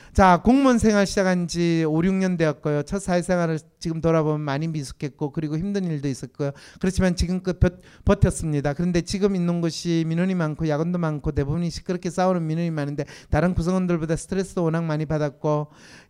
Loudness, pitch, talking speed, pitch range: -23 LUFS, 165 Hz, 415 characters per minute, 150-180 Hz